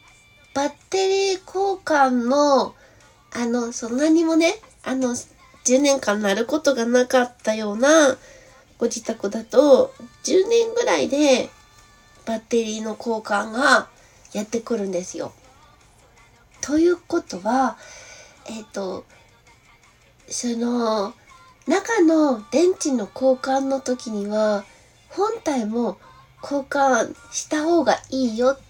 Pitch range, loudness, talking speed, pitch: 220-295 Hz, -21 LUFS, 200 characters per minute, 250 Hz